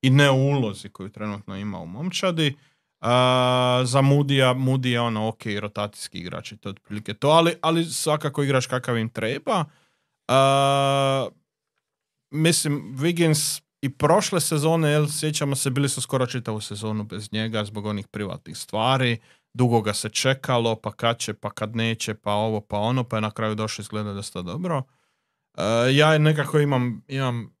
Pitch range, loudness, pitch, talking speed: 110-145 Hz, -23 LUFS, 125 Hz, 165 wpm